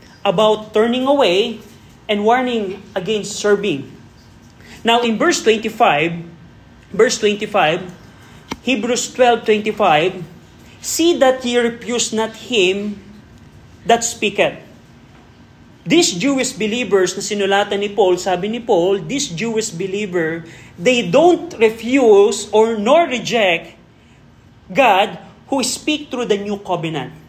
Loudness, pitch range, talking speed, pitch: -16 LUFS, 200-245 Hz, 110 wpm, 215 Hz